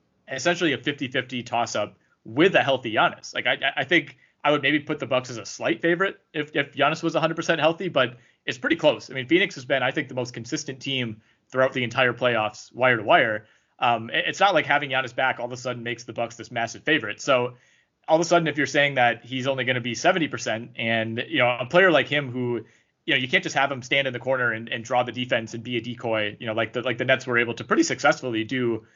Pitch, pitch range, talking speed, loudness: 130 Hz, 120-145 Hz, 255 wpm, -23 LUFS